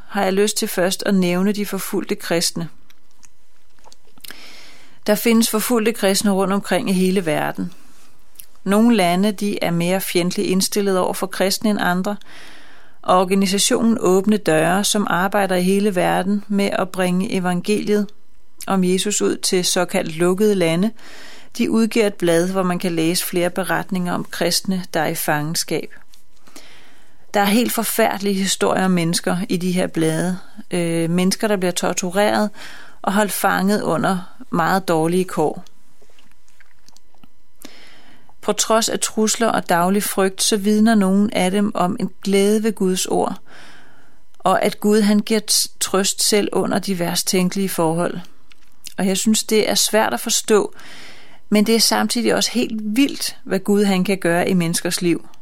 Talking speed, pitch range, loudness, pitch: 155 wpm, 180-210 Hz, -18 LUFS, 195 Hz